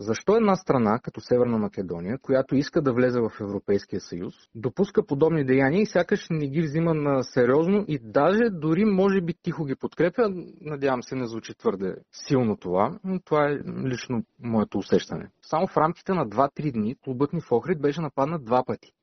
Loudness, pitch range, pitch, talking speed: -25 LUFS, 125-175 Hz, 150 Hz, 185 wpm